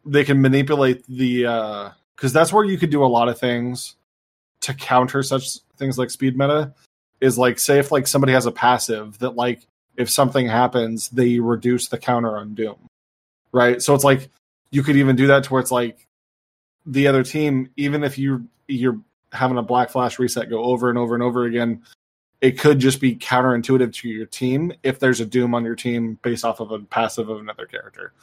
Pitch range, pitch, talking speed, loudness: 120-135 Hz, 125 Hz, 205 wpm, -19 LUFS